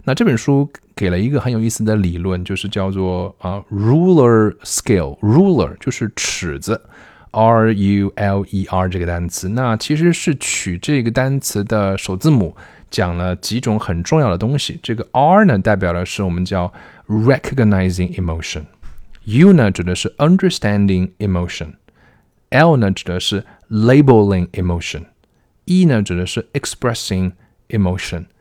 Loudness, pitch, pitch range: -16 LUFS, 100 Hz, 90-120 Hz